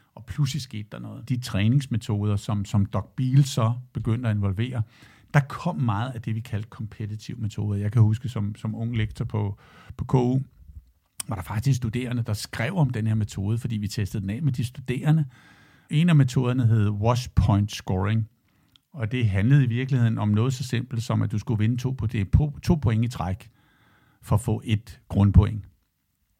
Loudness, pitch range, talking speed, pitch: -25 LUFS, 105-125 Hz, 195 wpm, 110 Hz